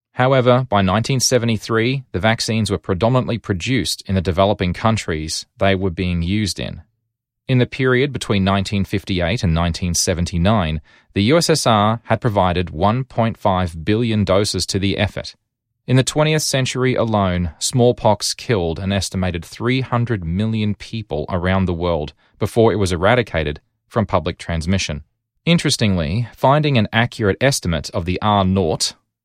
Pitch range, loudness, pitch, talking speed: 90-120 Hz, -18 LUFS, 105 Hz, 135 wpm